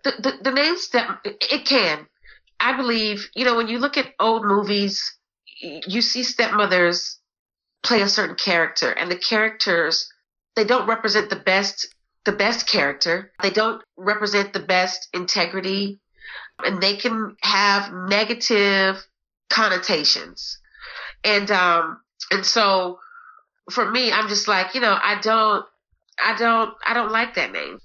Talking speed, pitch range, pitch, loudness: 145 wpm, 190-235 Hz, 210 Hz, -20 LUFS